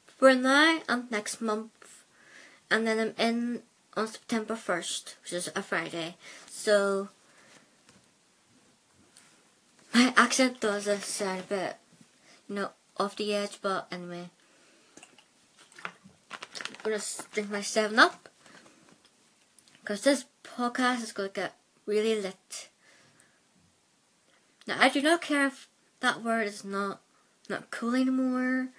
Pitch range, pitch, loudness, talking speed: 200-250 Hz, 215 Hz, -29 LUFS, 120 wpm